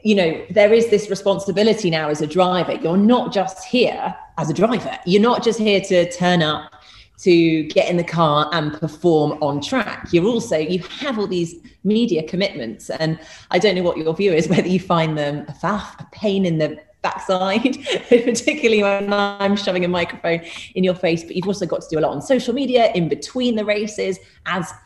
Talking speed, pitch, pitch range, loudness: 205 wpm, 185 Hz, 165-210 Hz, -19 LUFS